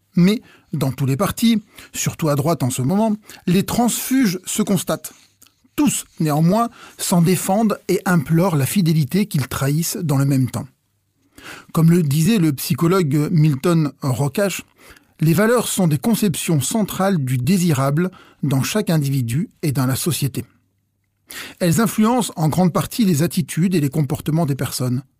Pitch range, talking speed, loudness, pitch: 140-195 Hz, 150 wpm, -19 LUFS, 165 Hz